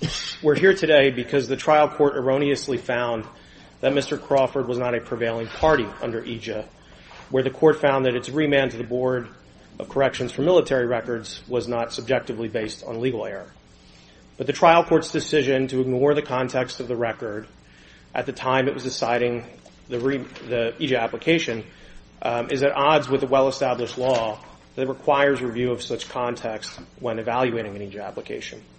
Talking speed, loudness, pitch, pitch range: 170 wpm, -23 LUFS, 130 Hz, 120-140 Hz